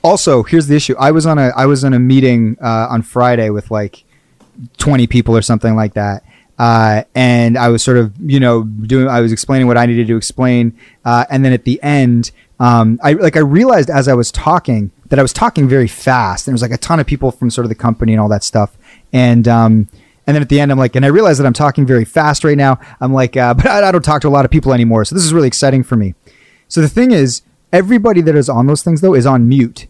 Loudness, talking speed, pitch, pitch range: -11 LUFS, 265 wpm, 125 Hz, 115-140 Hz